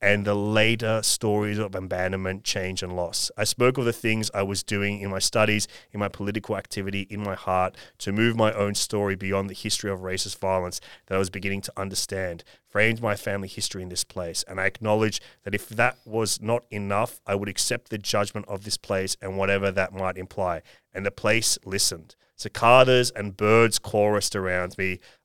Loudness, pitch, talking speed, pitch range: -25 LUFS, 100 Hz, 195 wpm, 95-110 Hz